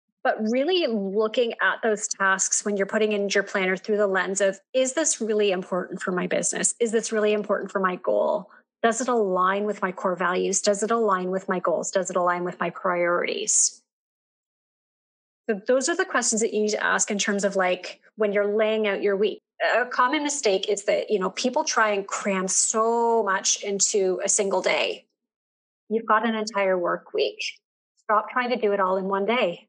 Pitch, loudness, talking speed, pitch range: 210 Hz, -23 LUFS, 205 wpm, 190-230 Hz